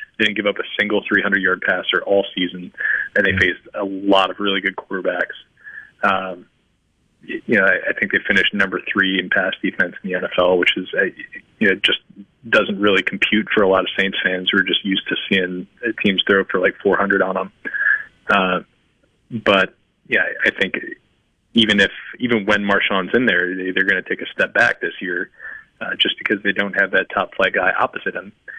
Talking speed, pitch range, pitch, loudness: 200 wpm, 95-100 Hz, 95 Hz, -18 LUFS